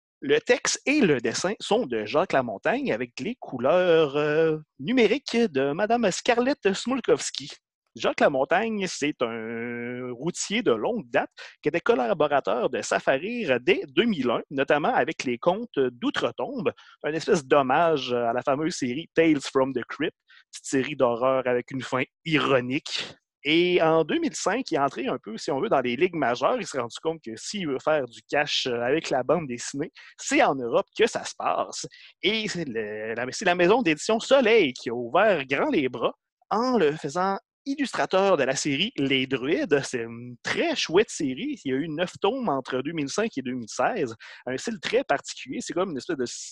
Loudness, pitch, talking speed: -25 LUFS, 160 Hz, 180 wpm